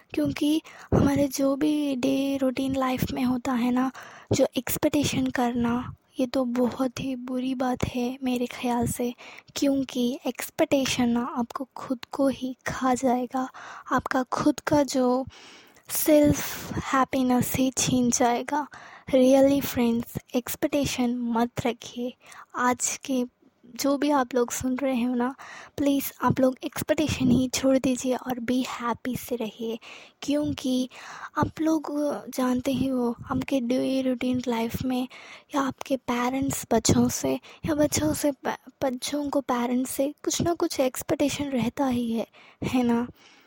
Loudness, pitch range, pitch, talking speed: -26 LUFS, 245-275 Hz, 260 Hz, 140 wpm